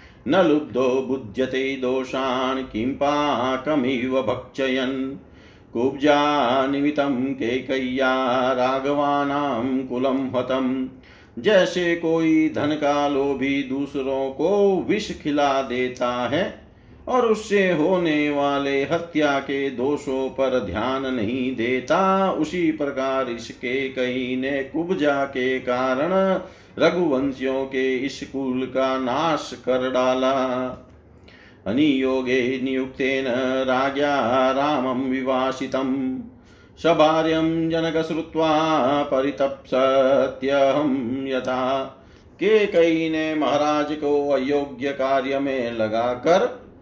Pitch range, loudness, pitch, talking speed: 130-145 Hz, -22 LUFS, 135 Hz, 90 wpm